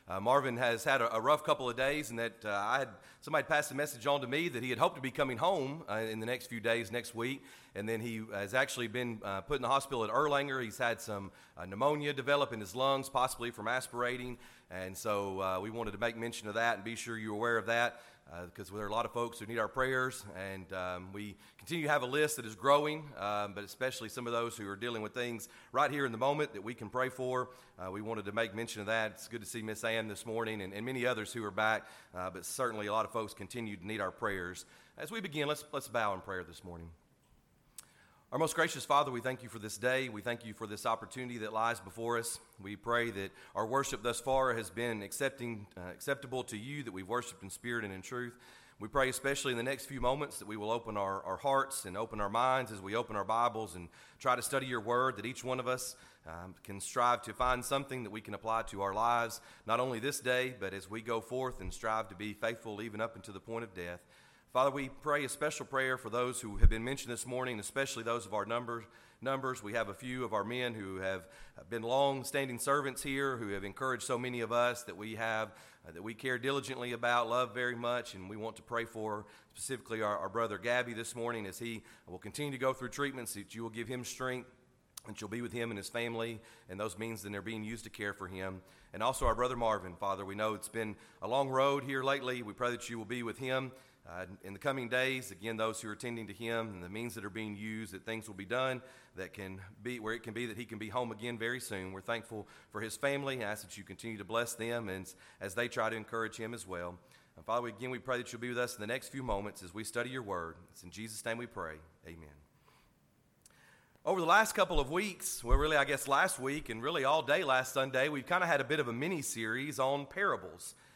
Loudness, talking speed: -36 LUFS, 255 wpm